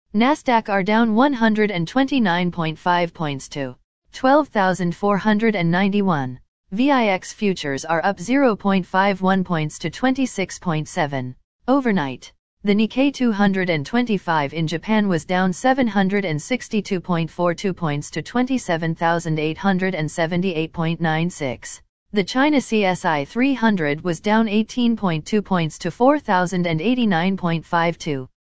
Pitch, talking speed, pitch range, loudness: 185 Hz, 80 wpm, 165-220 Hz, -20 LUFS